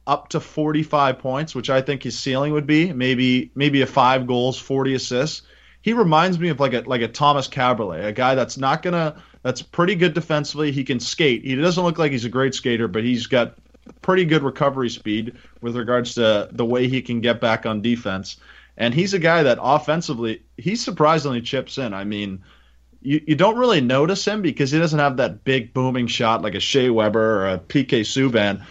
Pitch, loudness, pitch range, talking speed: 130 Hz, -20 LUFS, 120-150 Hz, 210 wpm